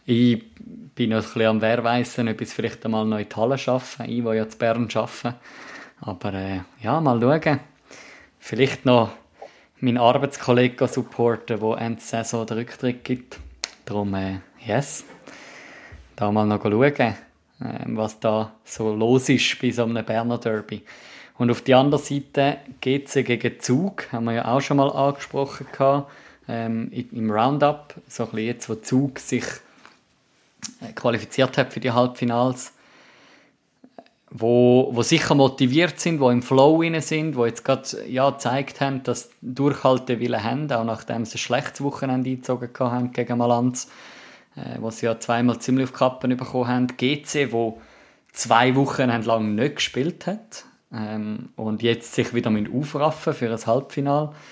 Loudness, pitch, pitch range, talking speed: -22 LUFS, 125 Hz, 115-135 Hz, 160 wpm